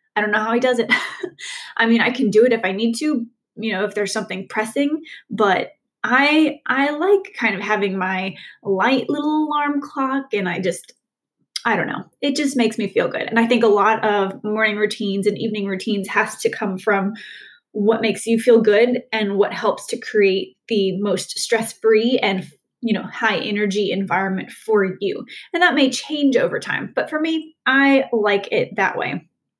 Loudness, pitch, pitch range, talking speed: -19 LUFS, 225 Hz, 205-275 Hz, 195 wpm